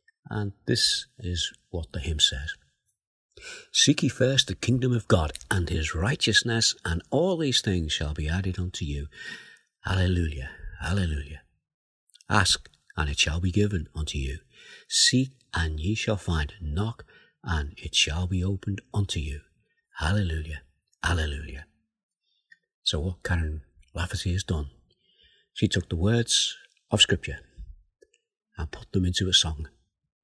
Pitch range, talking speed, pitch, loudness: 80-115 Hz, 135 wpm, 95 Hz, -26 LUFS